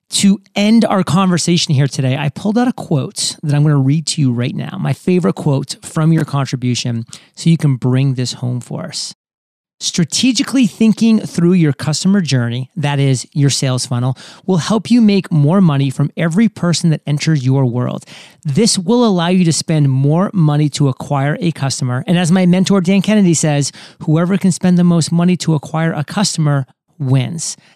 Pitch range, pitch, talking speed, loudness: 140-185 Hz, 160 Hz, 190 wpm, -14 LUFS